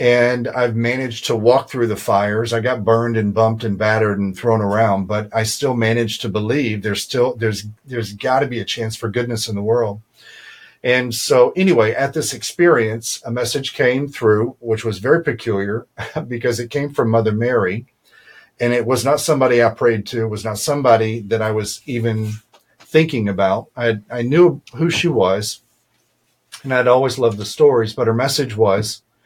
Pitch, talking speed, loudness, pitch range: 115 Hz, 190 wpm, -18 LUFS, 110-125 Hz